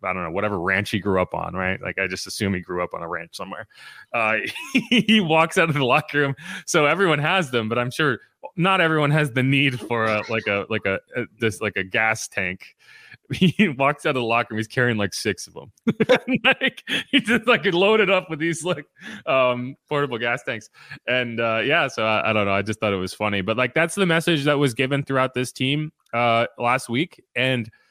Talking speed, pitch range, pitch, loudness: 230 wpm, 110-165 Hz, 130 Hz, -21 LUFS